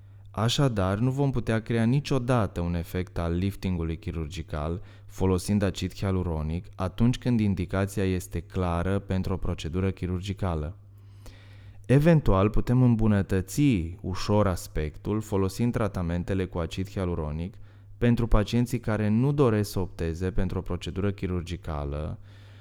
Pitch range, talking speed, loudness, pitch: 90-105 Hz, 115 wpm, -27 LUFS, 95 Hz